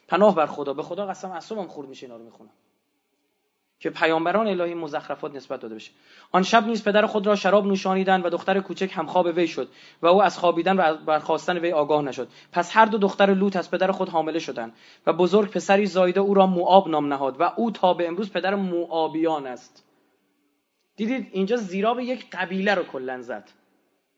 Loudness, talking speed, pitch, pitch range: -23 LUFS, 190 wpm, 180 Hz, 155-195 Hz